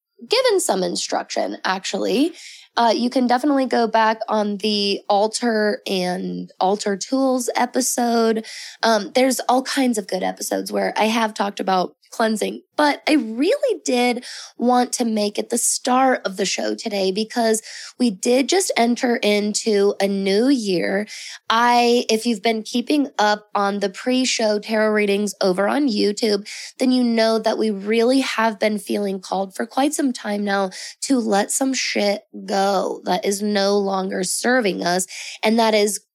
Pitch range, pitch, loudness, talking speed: 200-250 Hz, 220 Hz, -20 LUFS, 160 wpm